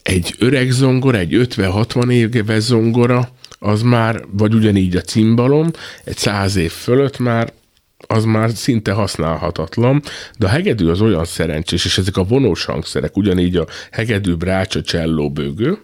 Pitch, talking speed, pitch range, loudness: 110 Hz, 150 wpm, 90-120 Hz, -16 LUFS